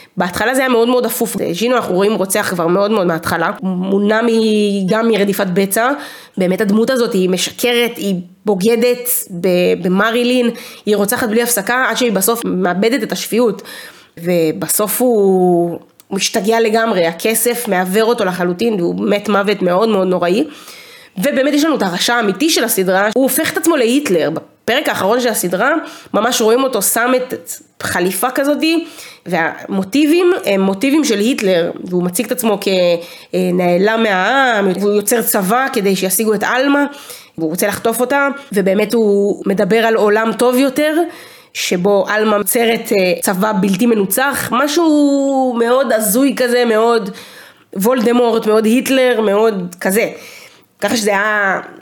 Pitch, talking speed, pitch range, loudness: 220 Hz, 140 wpm, 195-245 Hz, -14 LUFS